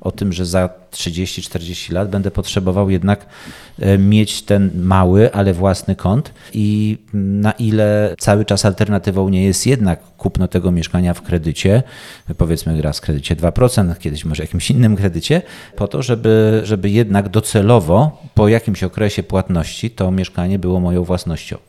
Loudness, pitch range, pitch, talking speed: -16 LUFS, 90-105 Hz, 100 Hz, 150 wpm